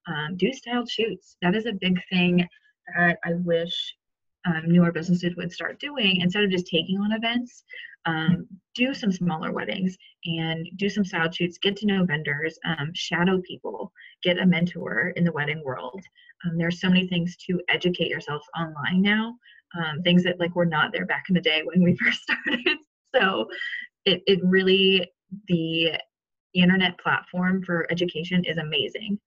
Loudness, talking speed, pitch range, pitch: -24 LUFS, 170 wpm, 170-195 Hz, 180 Hz